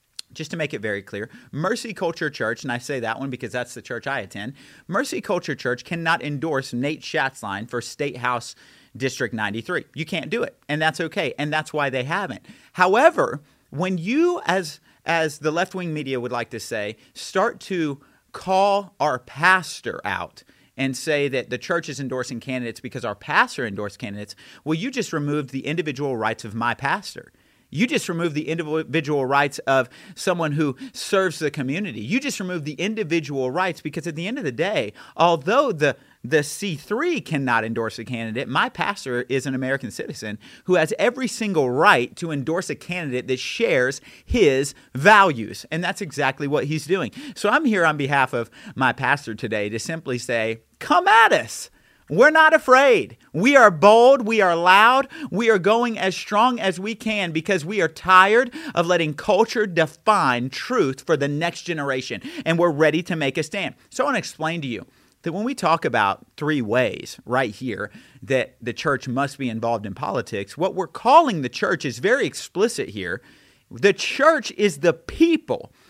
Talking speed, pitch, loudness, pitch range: 185 wpm, 160 Hz, -21 LUFS, 135-195 Hz